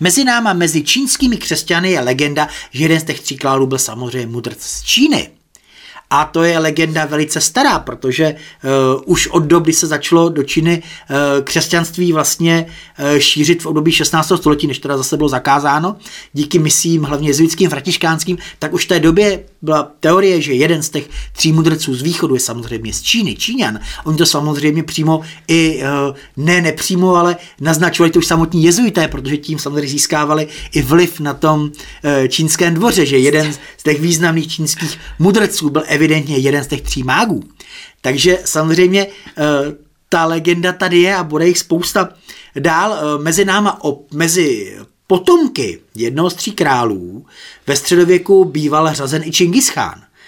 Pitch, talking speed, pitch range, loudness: 160 Hz, 165 wpm, 150-175 Hz, -14 LUFS